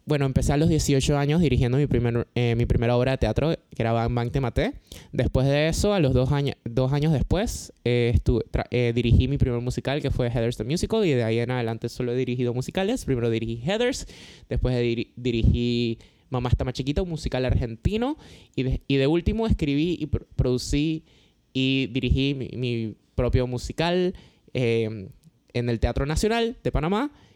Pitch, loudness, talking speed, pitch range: 125 Hz, -25 LUFS, 195 wpm, 120-145 Hz